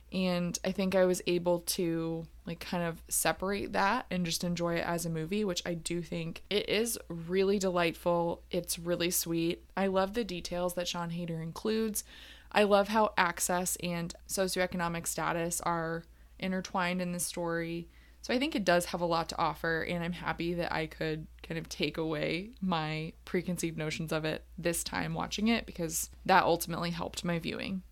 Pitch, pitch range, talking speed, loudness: 175 Hz, 165-185 Hz, 185 wpm, -32 LUFS